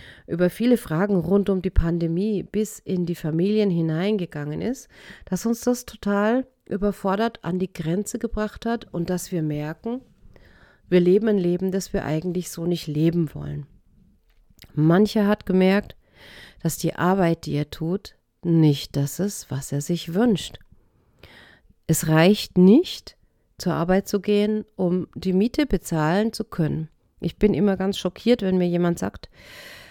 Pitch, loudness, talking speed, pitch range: 185 Hz, -23 LUFS, 155 wpm, 165-205 Hz